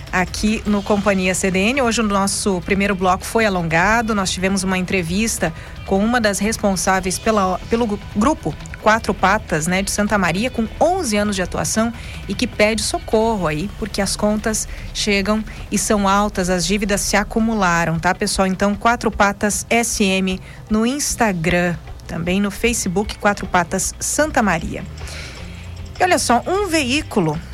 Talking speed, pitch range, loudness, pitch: 150 wpm, 185-225 Hz, -18 LUFS, 205 Hz